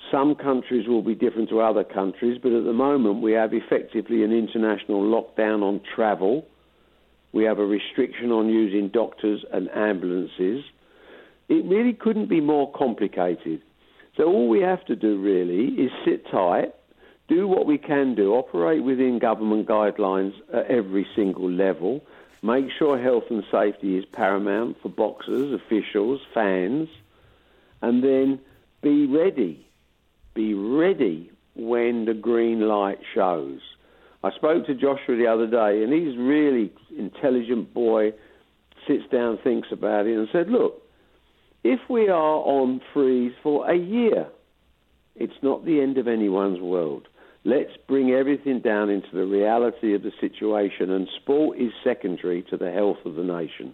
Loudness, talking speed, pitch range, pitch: -23 LUFS, 150 wpm, 105-140 Hz, 115 Hz